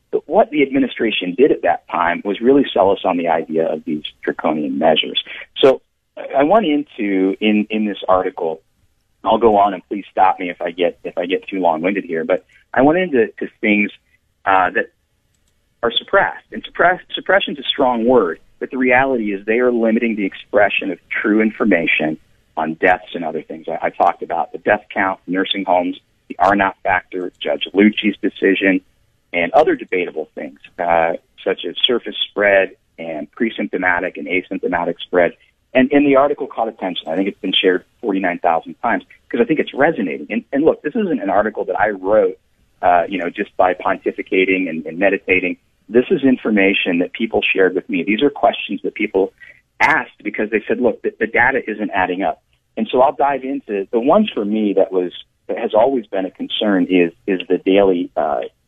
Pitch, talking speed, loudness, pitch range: 105 Hz, 195 wpm, -17 LUFS, 95-130 Hz